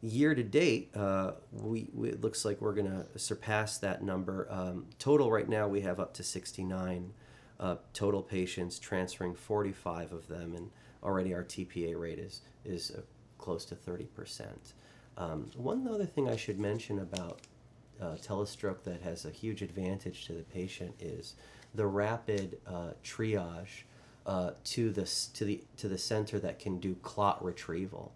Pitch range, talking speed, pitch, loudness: 90-110 Hz, 165 wpm, 100 Hz, -36 LUFS